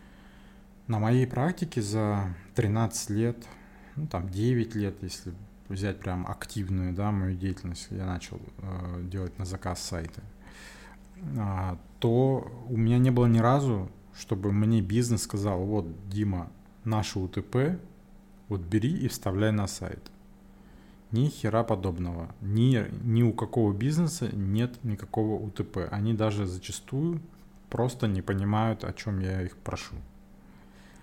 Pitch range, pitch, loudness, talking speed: 95-120 Hz, 105 Hz, -29 LUFS, 130 wpm